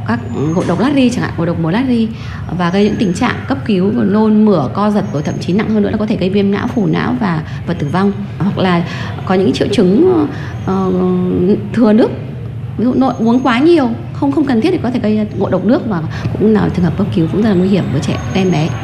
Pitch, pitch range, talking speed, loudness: 190 Hz, 165-215 Hz, 265 wpm, -14 LUFS